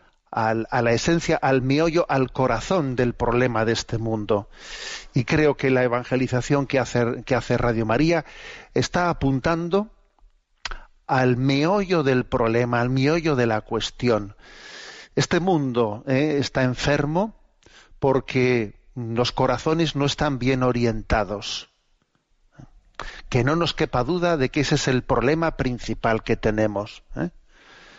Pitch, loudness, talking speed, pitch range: 130 Hz, -22 LUFS, 135 wpm, 120-150 Hz